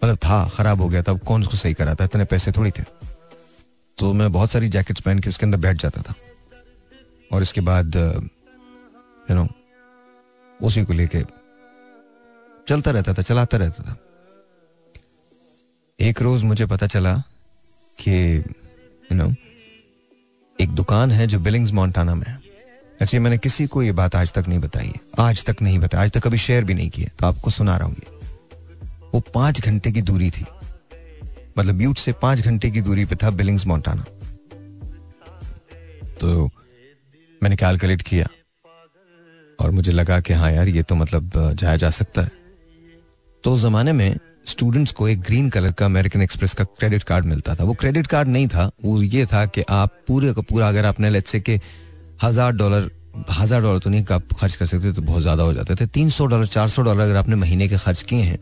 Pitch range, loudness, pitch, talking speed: 90-120 Hz, -19 LUFS, 100 Hz, 185 wpm